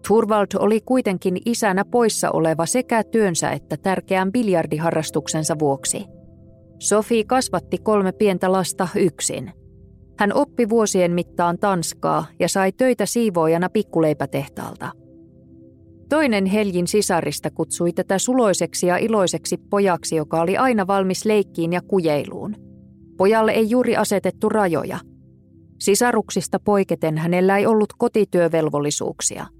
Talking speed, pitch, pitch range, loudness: 110 wpm, 190 Hz, 165-215 Hz, -20 LUFS